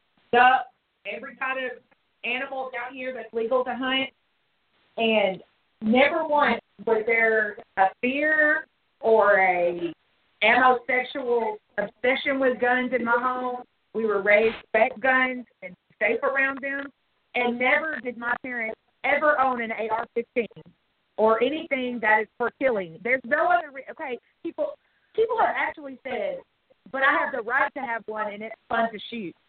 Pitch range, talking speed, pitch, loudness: 225-270 Hz, 150 wpm, 245 Hz, -24 LUFS